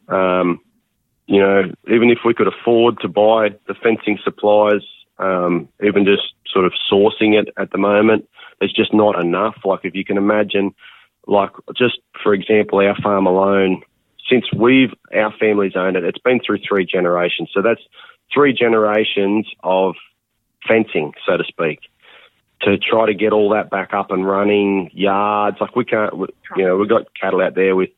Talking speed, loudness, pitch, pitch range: 175 wpm, -16 LUFS, 100 Hz, 95-110 Hz